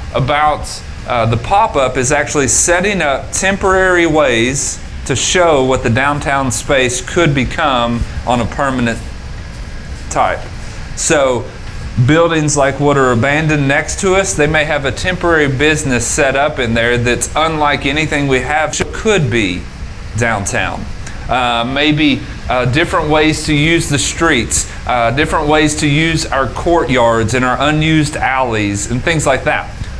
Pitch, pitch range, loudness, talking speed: 135 Hz, 115-155 Hz, -13 LUFS, 150 wpm